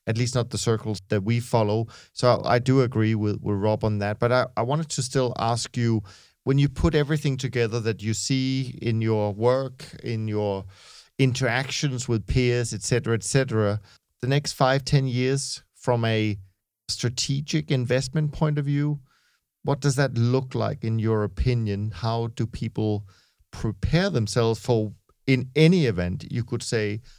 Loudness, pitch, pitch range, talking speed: -25 LUFS, 120 Hz, 110-135 Hz, 170 wpm